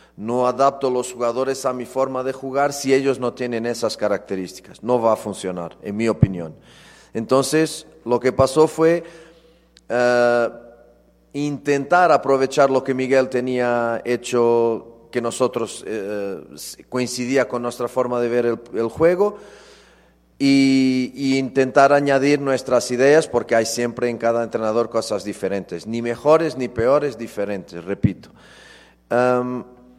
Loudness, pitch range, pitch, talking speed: -20 LUFS, 115-135 Hz, 125 Hz, 135 wpm